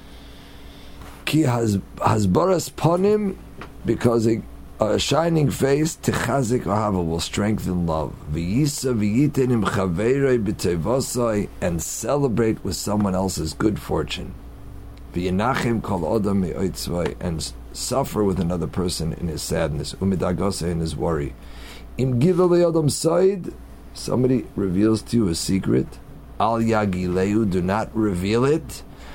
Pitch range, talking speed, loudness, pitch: 90-130 Hz, 90 wpm, -22 LUFS, 105 Hz